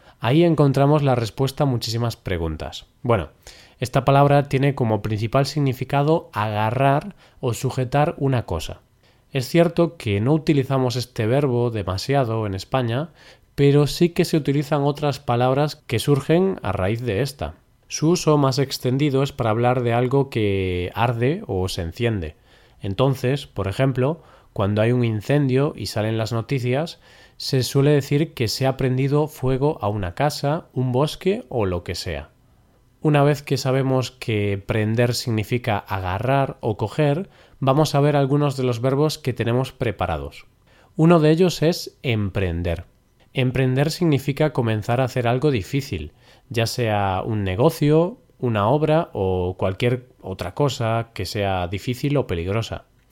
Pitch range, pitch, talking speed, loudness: 110-145 Hz, 130 Hz, 150 wpm, -21 LUFS